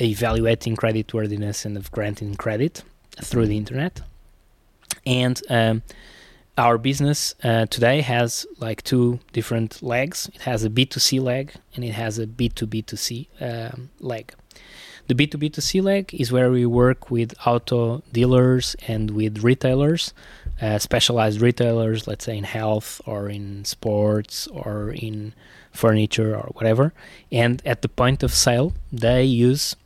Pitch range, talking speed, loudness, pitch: 110-125 Hz, 135 wpm, -22 LUFS, 120 Hz